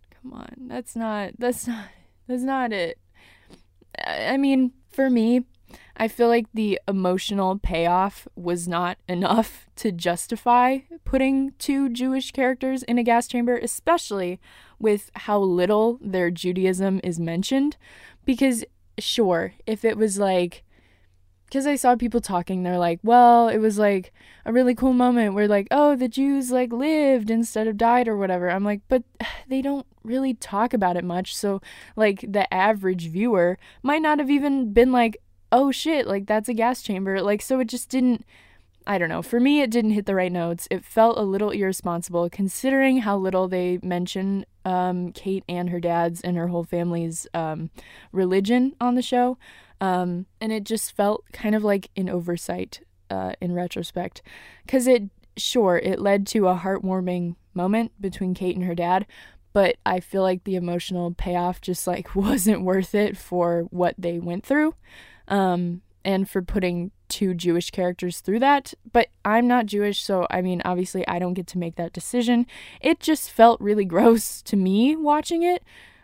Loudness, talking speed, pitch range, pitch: -23 LUFS, 170 wpm, 180-245 Hz, 205 Hz